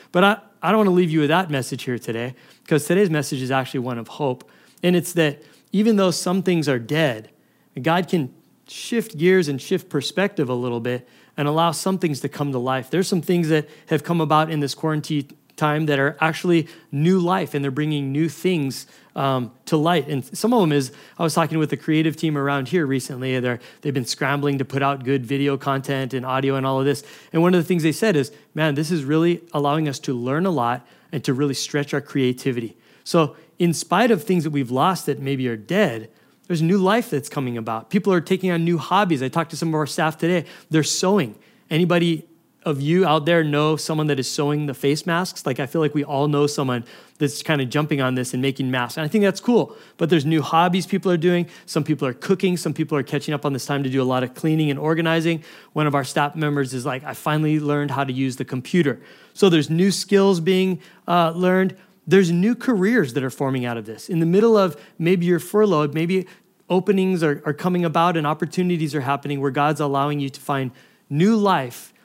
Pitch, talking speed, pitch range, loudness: 155 Hz, 230 wpm, 140-175 Hz, -21 LUFS